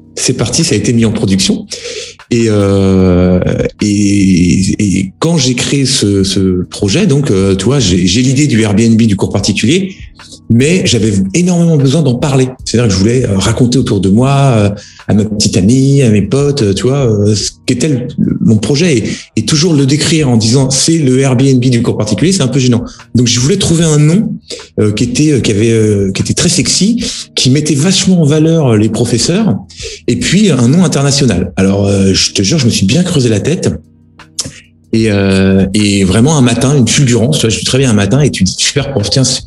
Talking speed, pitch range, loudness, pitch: 195 wpm, 100-140 Hz, -10 LUFS, 120 Hz